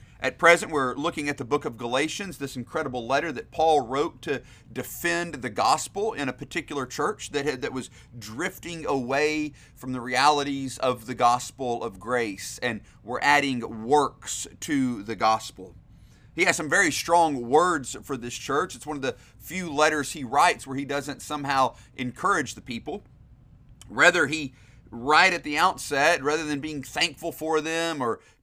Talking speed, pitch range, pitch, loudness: 170 wpm, 120-150 Hz, 135 Hz, -25 LUFS